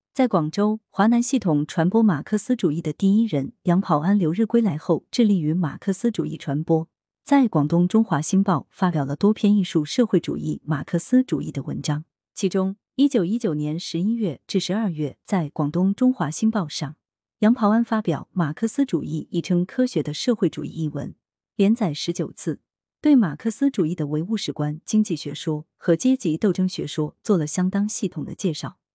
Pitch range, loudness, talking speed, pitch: 155-215 Hz, -22 LUFS, 290 characters per minute, 180 Hz